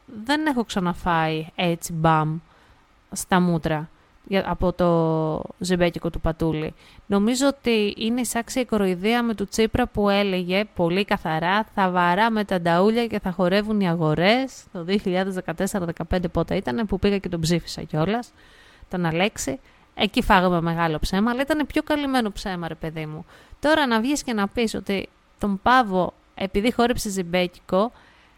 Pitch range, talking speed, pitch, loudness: 170-225 Hz, 150 wpm, 195 Hz, -23 LUFS